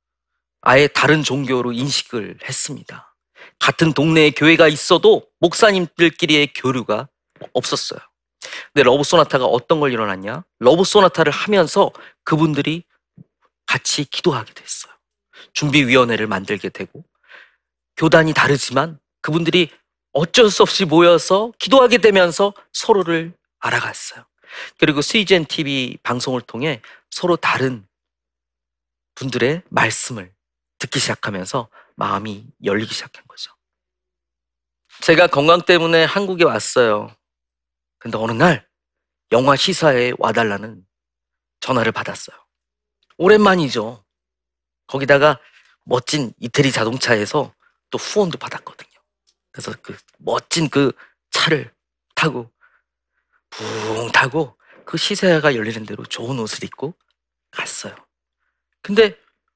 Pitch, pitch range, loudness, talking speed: 140 Hz, 105-165 Hz, -16 LUFS, 260 characters per minute